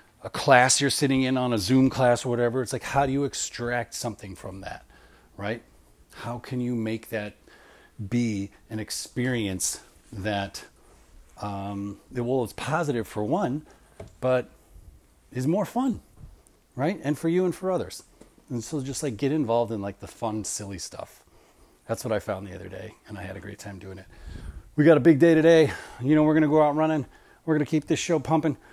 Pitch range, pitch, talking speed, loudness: 105-145 Hz, 120 Hz, 200 wpm, -25 LUFS